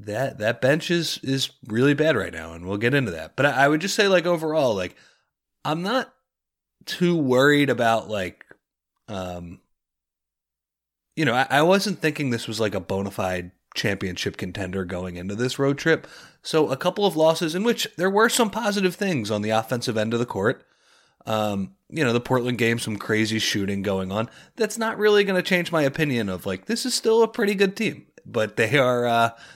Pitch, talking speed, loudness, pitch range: 125 Hz, 200 wpm, -23 LUFS, 100-165 Hz